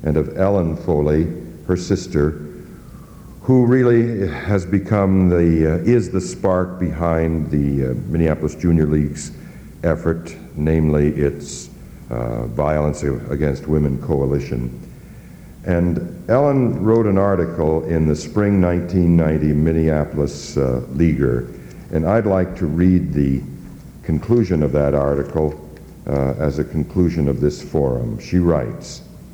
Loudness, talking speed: -18 LUFS, 125 wpm